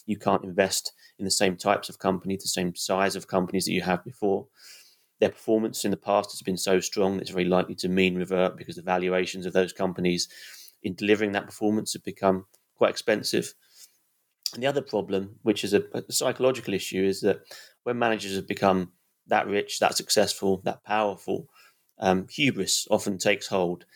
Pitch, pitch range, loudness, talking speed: 95 Hz, 95-105 Hz, -26 LUFS, 185 wpm